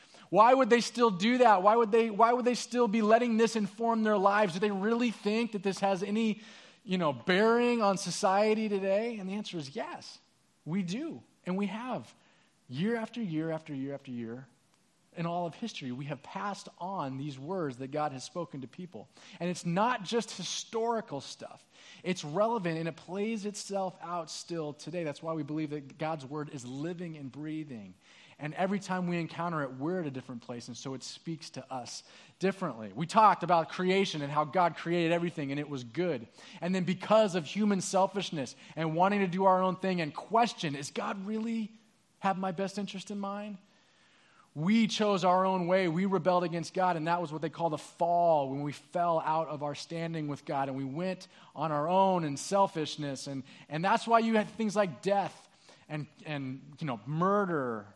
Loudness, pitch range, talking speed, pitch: -31 LUFS, 155-205 Hz, 200 wpm, 180 Hz